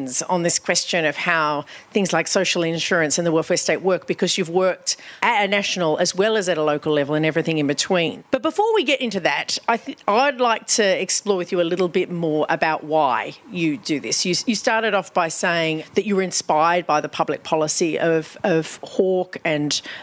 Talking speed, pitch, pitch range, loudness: 215 wpm, 180 Hz, 160-195 Hz, -20 LUFS